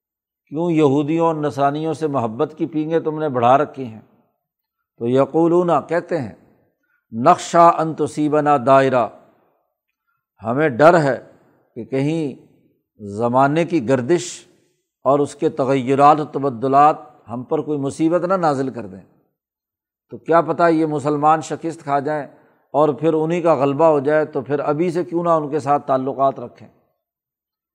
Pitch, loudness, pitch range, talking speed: 150 Hz, -18 LUFS, 135-165 Hz, 145 wpm